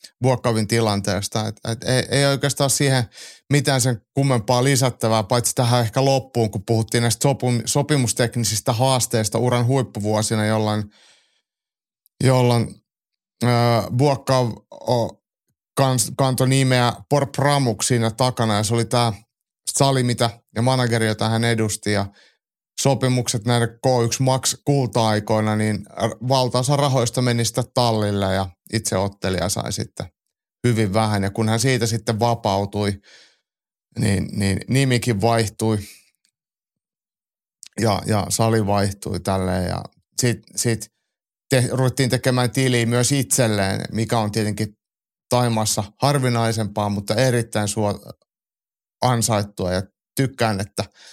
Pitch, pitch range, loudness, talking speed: 115 Hz, 110-130 Hz, -20 LUFS, 115 wpm